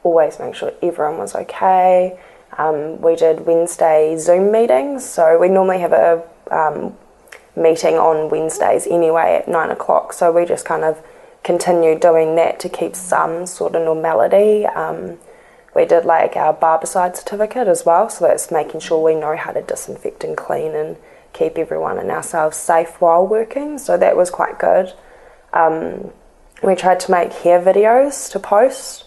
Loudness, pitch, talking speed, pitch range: -16 LUFS, 175 Hz, 165 wpm, 165-215 Hz